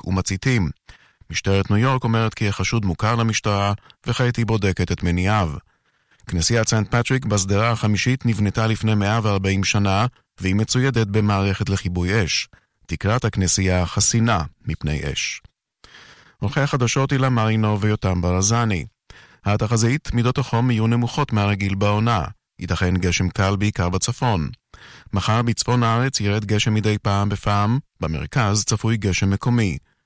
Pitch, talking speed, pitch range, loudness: 105 Hz, 125 wpm, 95-115 Hz, -20 LUFS